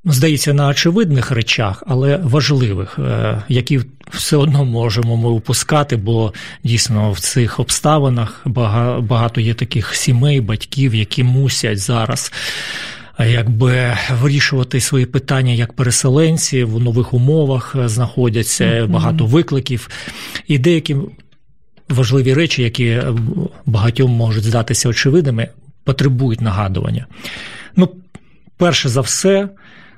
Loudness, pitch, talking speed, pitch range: -15 LUFS, 130 Hz, 105 wpm, 115-145 Hz